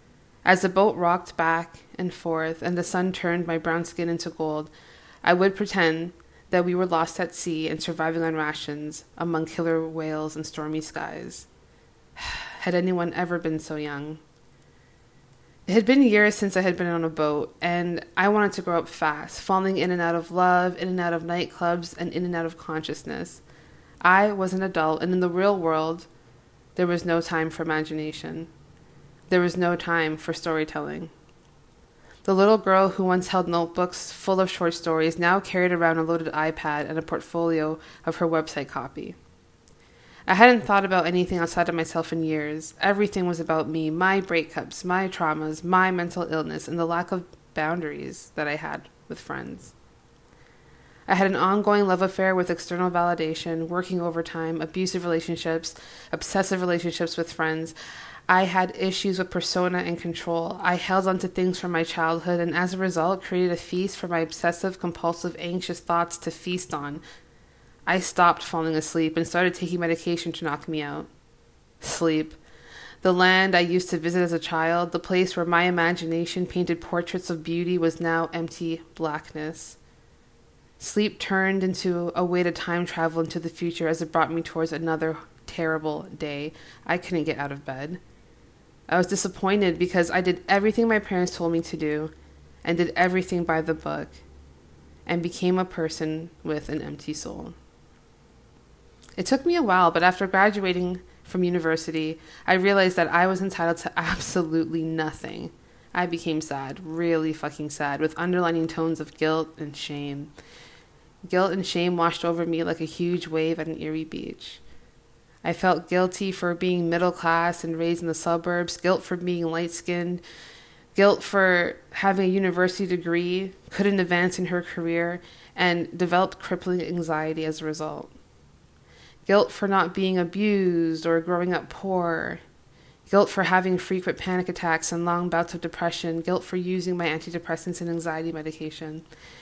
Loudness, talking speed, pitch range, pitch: -25 LUFS, 170 wpm, 160-180 Hz, 170 Hz